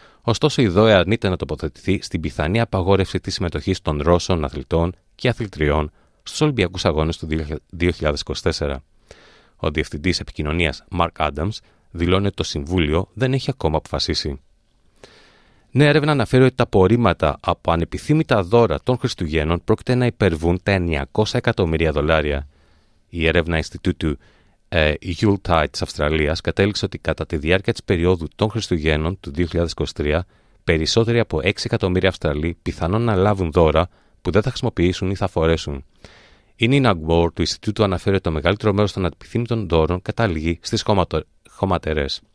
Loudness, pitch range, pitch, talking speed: -20 LUFS, 80-110 Hz, 90 Hz, 145 wpm